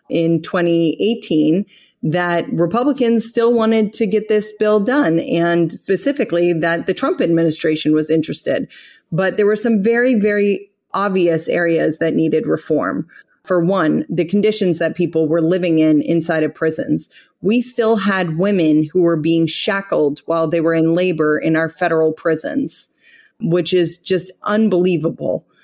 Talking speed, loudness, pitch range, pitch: 145 wpm, -17 LUFS, 165-210 Hz, 175 Hz